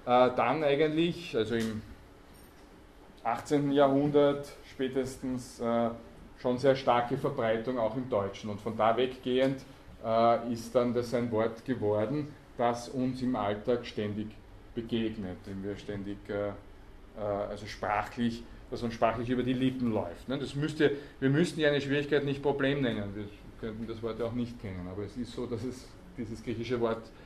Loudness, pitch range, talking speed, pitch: -31 LUFS, 105-130 Hz, 165 wpm, 120 Hz